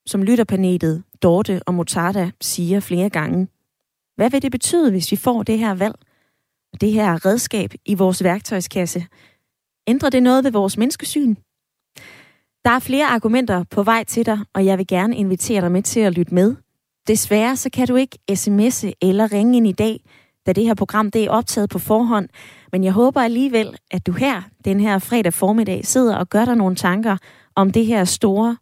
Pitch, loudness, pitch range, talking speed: 210 Hz, -18 LUFS, 185-230 Hz, 190 wpm